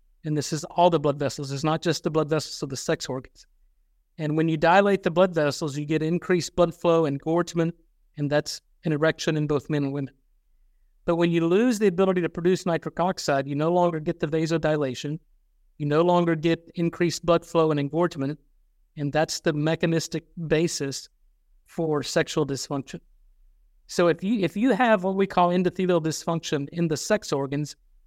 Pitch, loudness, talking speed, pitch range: 160 Hz, -25 LUFS, 190 wpm, 145-175 Hz